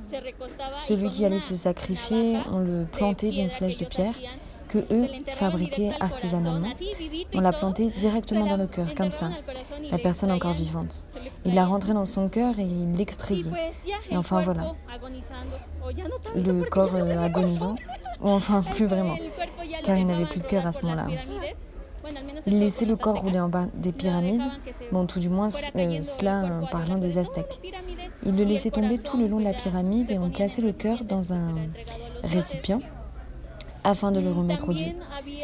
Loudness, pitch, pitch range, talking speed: -26 LUFS, 195 Hz, 180-225 Hz, 170 wpm